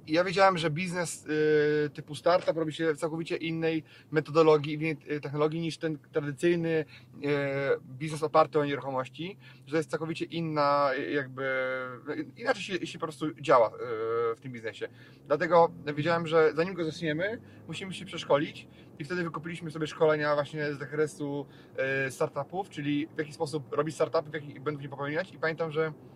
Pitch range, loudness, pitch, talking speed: 145-165 Hz, -30 LUFS, 155 Hz, 155 wpm